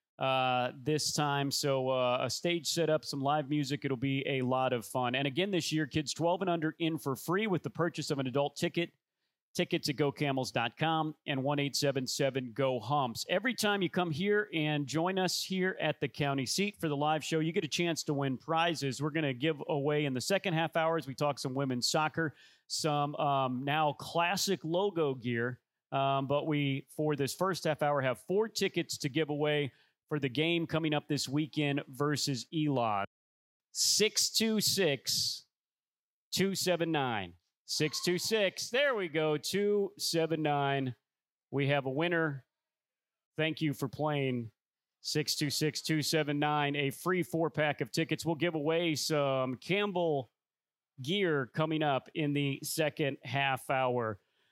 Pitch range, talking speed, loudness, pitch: 135-165 Hz, 160 wpm, -32 LUFS, 150 Hz